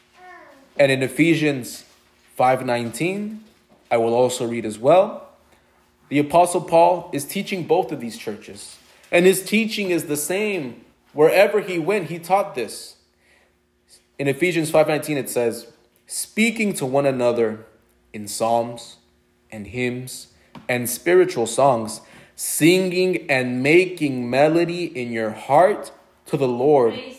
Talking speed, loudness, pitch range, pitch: 125 wpm, -20 LUFS, 120-180 Hz, 140 Hz